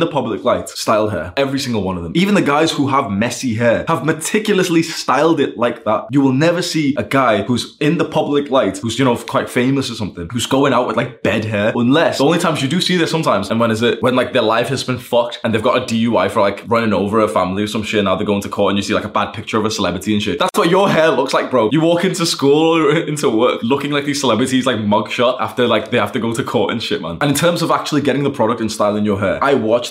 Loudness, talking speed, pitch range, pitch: -16 LUFS, 290 wpm, 110-150 Hz, 130 Hz